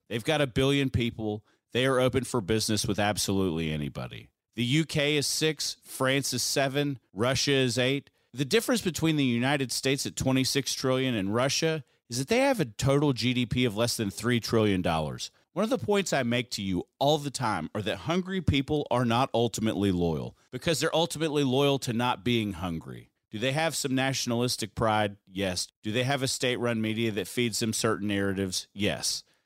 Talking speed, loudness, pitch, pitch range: 190 wpm, -28 LUFS, 125 Hz, 110-140 Hz